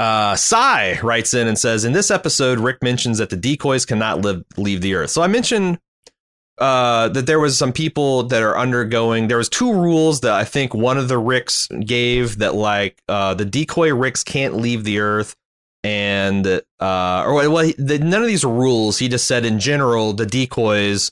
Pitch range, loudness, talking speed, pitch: 105-140 Hz, -17 LUFS, 200 wpm, 120 Hz